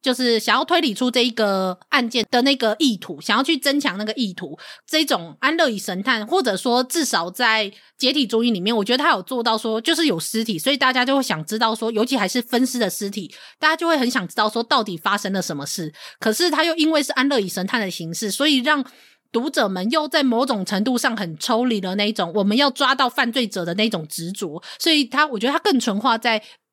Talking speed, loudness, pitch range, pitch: 340 characters per minute, -20 LUFS, 205-275 Hz, 235 Hz